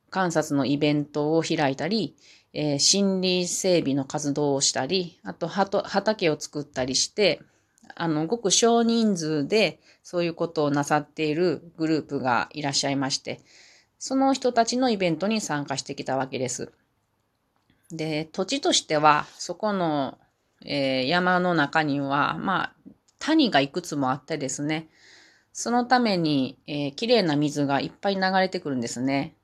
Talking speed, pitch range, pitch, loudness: 295 characters per minute, 145-190 Hz, 155 Hz, -24 LUFS